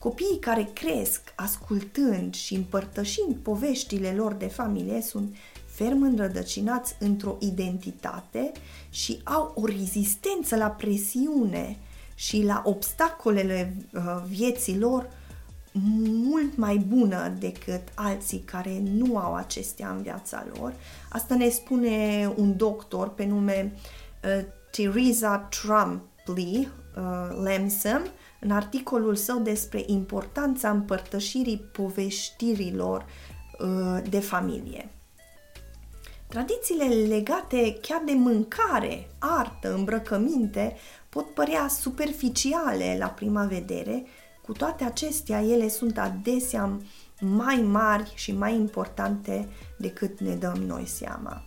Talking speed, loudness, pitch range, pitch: 105 wpm, -27 LUFS, 195-240 Hz, 210 Hz